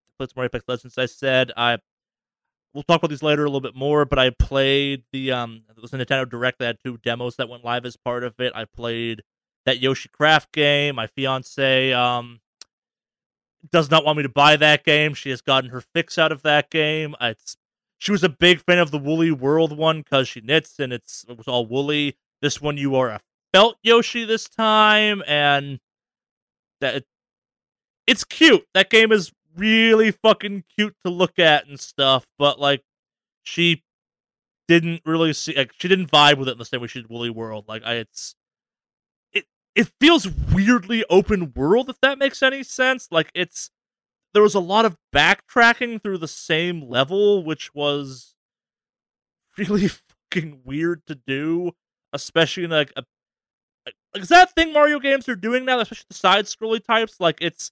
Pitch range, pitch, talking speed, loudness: 130-195 Hz, 150 Hz, 190 wpm, -19 LUFS